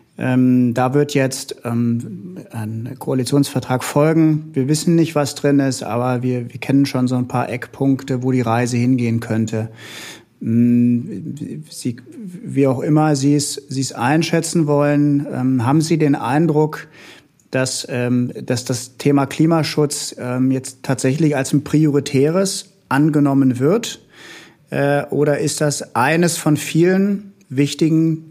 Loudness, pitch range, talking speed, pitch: -18 LUFS, 125-155 Hz, 125 wpm, 140 Hz